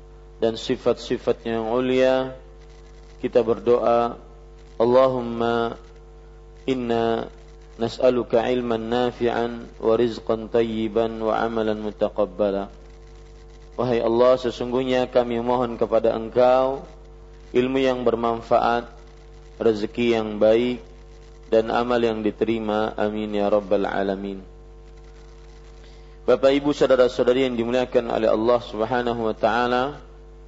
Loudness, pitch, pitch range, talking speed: -22 LUFS, 115 Hz, 110-125 Hz, 95 wpm